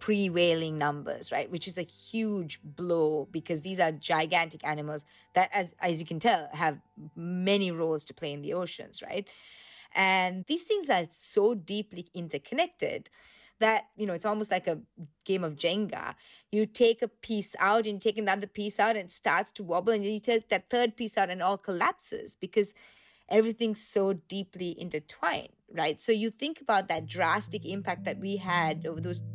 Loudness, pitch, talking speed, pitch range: -30 LUFS, 190 Hz, 185 wpm, 170-215 Hz